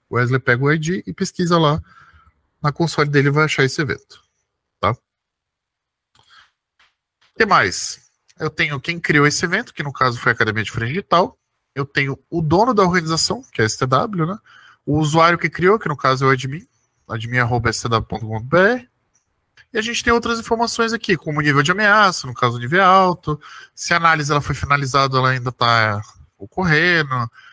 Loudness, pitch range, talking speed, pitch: -17 LUFS, 130-180 Hz, 180 wpm, 150 Hz